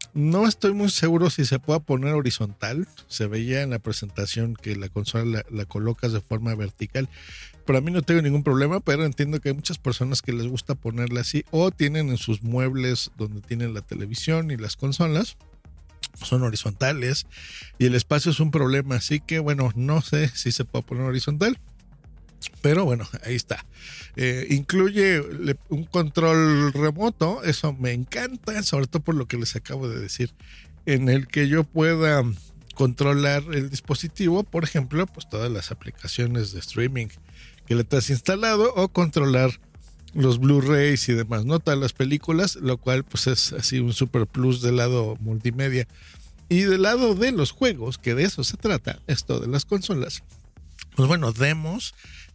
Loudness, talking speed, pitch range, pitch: -23 LUFS, 170 wpm, 115-155 Hz, 130 Hz